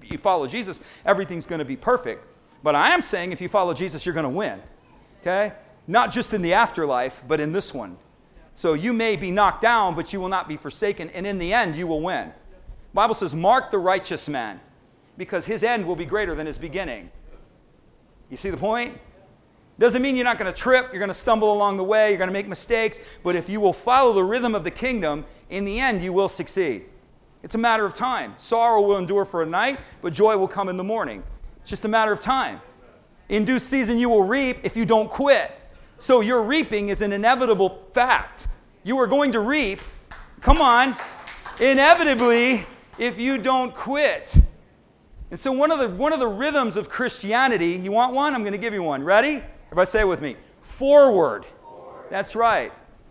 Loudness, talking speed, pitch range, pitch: -21 LUFS, 210 wpm, 190-250 Hz, 215 Hz